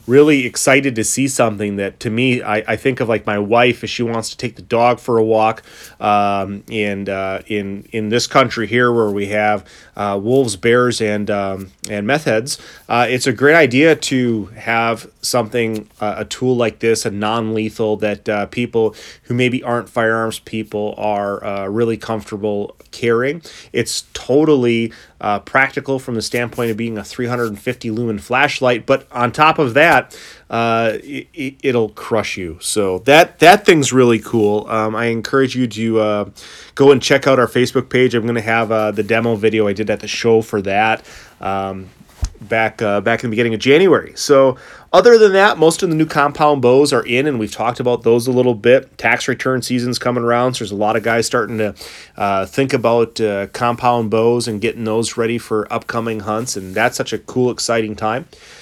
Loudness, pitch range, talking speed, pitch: -16 LUFS, 105-125 Hz, 200 wpm, 115 Hz